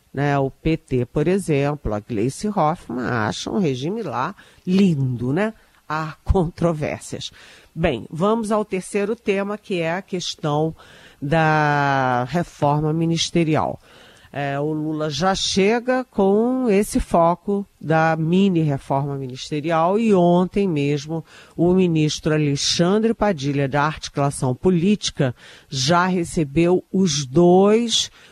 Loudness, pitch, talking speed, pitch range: -20 LUFS, 165 Hz, 110 wpm, 145-190 Hz